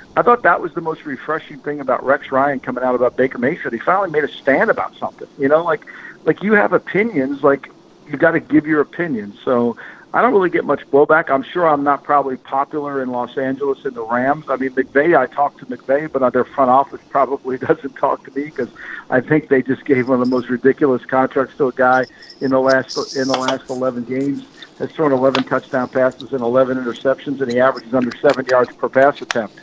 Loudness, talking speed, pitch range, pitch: -17 LUFS, 225 wpm, 130-145 Hz, 135 Hz